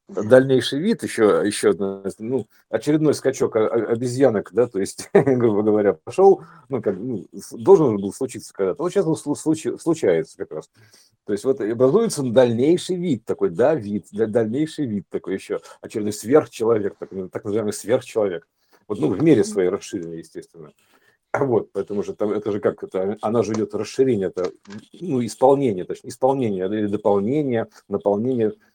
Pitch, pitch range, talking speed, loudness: 125 Hz, 105-145 Hz, 155 wpm, -21 LUFS